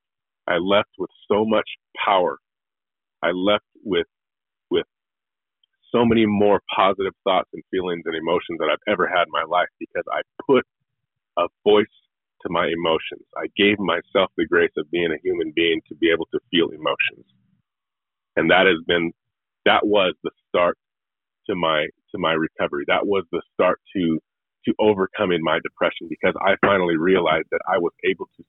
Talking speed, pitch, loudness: 170 wpm, 310 Hz, -21 LUFS